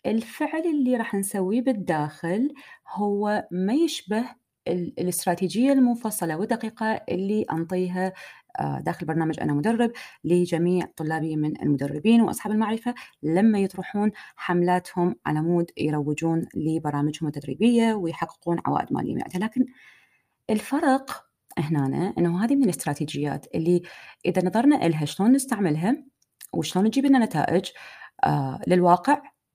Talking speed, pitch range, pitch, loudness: 105 wpm, 165-235 Hz, 190 Hz, -24 LUFS